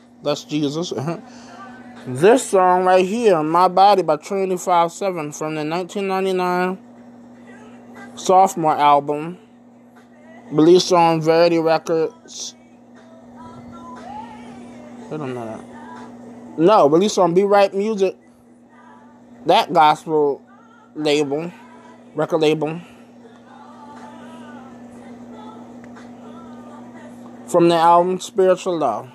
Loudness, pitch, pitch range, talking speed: -17 LUFS, 185 Hz, 165-245 Hz, 85 wpm